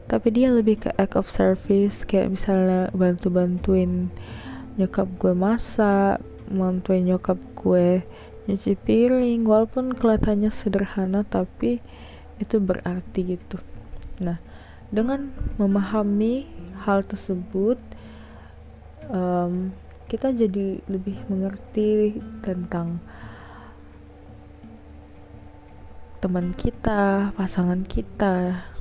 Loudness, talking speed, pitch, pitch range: -23 LUFS, 85 wpm, 190 Hz, 170-210 Hz